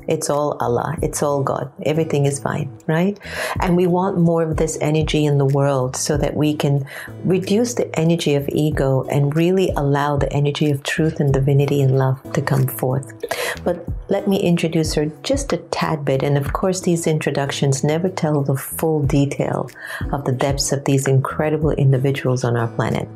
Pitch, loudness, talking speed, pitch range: 145 Hz, -19 LUFS, 185 wpm, 140-160 Hz